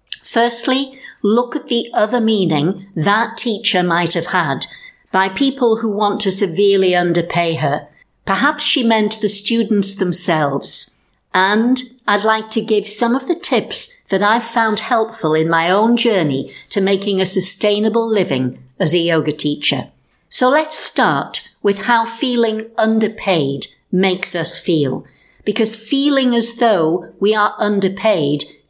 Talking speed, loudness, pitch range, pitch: 140 wpm, -15 LUFS, 175-230 Hz, 205 Hz